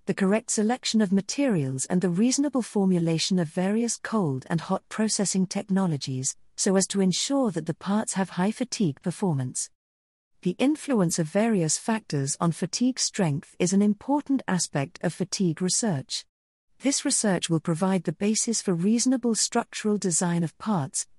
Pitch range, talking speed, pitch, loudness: 170-220 Hz, 155 wpm, 190 Hz, -25 LUFS